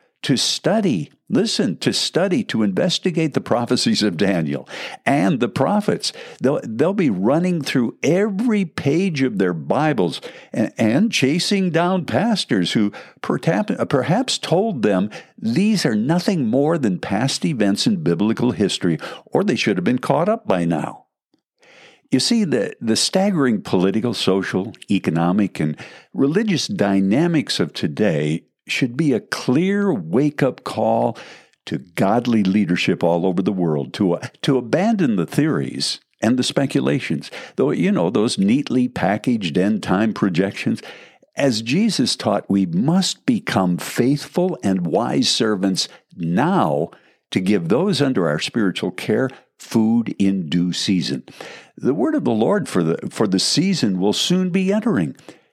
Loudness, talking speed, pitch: -19 LUFS, 145 wpm, 135 Hz